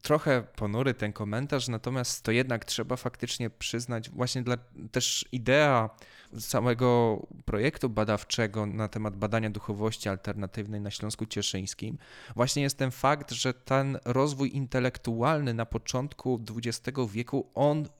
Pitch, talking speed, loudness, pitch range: 120 Hz, 125 wpm, -30 LUFS, 110-130 Hz